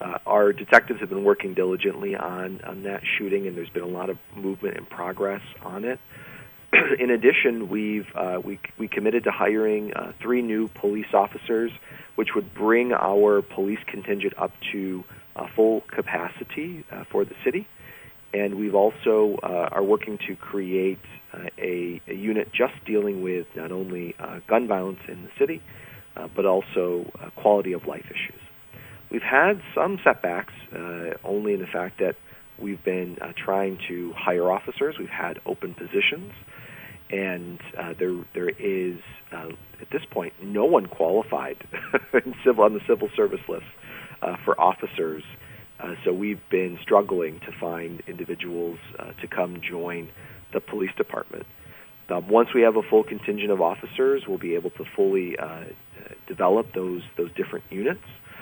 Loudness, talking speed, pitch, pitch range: -25 LUFS, 165 wpm, 100 Hz, 90-105 Hz